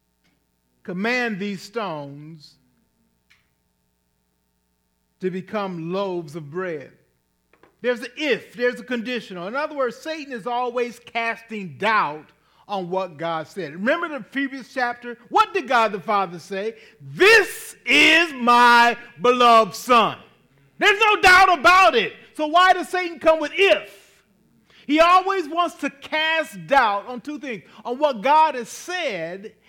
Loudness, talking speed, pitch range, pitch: -19 LUFS, 135 wpm, 185-295 Hz, 235 Hz